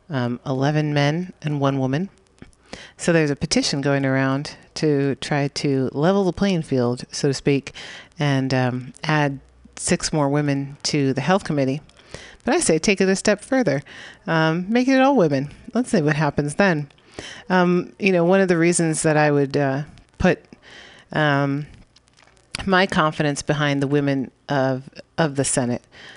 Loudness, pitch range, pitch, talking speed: -21 LUFS, 140-175 Hz, 150 Hz, 165 wpm